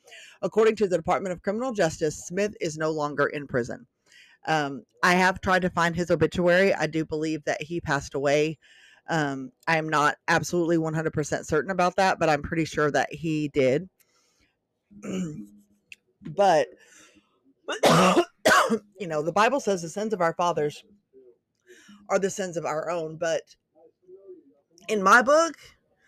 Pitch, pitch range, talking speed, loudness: 170 Hz, 155-200 Hz, 150 wpm, -25 LUFS